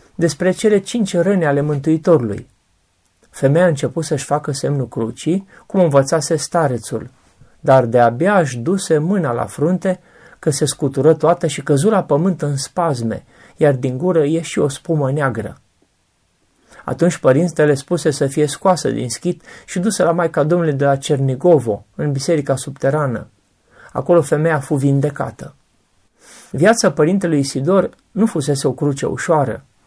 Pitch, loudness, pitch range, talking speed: 155 Hz, -17 LUFS, 140-175 Hz, 145 wpm